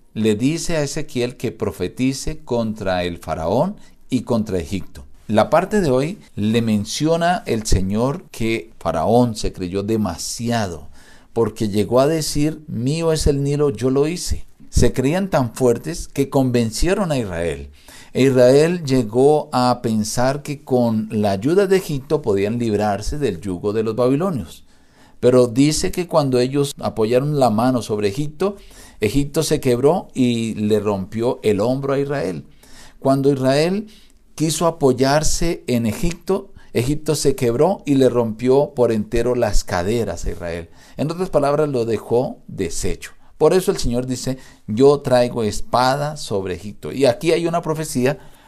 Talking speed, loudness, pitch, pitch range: 150 wpm, -19 LUFS, 125 Hz, 110-150 Hz